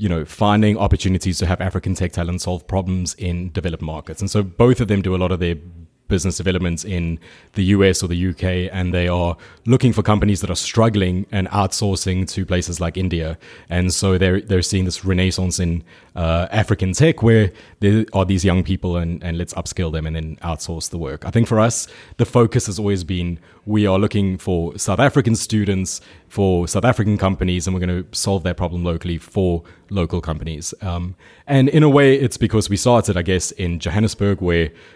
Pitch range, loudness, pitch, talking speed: 90-105 Hz, -19 LUFS, 95 Hz, 205 wpm